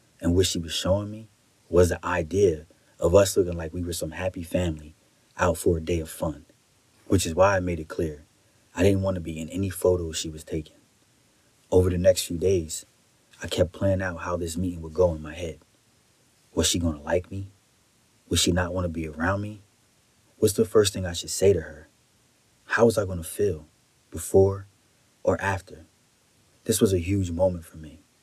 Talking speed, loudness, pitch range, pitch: 210 wpm, -25 LUFS, 80-95 Hz, 90 Hz